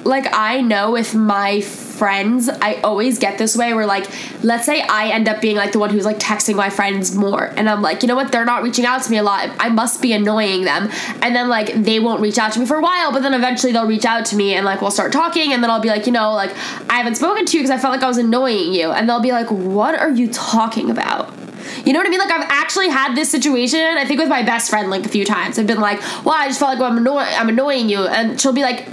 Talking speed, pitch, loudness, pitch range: 290 wpm, 235 Hz, -16 LUFS, 210-265 Hz